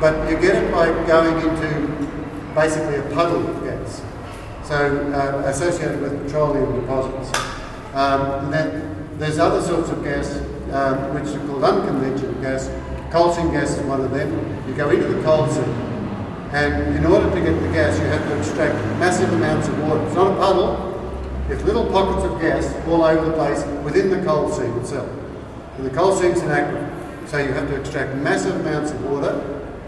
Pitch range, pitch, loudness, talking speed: 135-155 Hz, 145 Hz, -20 LUFS, 185 wpm